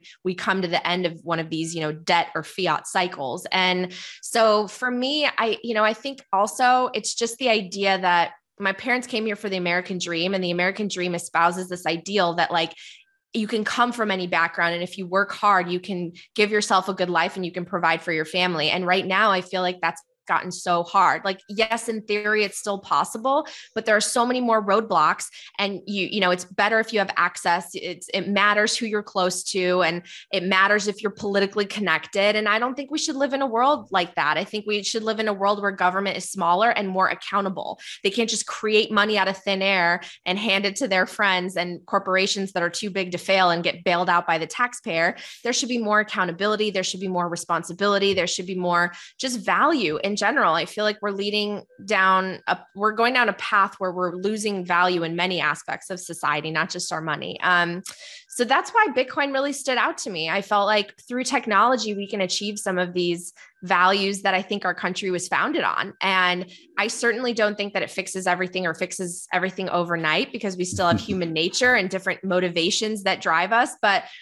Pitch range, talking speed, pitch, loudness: 180-215 Hz, 225 wpm, 195 Hz, -22 LUFS